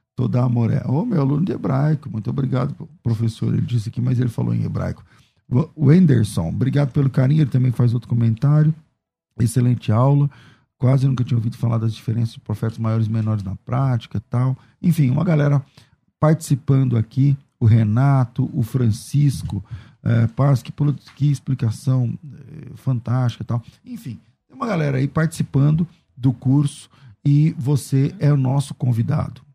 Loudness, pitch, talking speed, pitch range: -20 LUFS, 130 Hz, 155 wpm, 120-145 Hz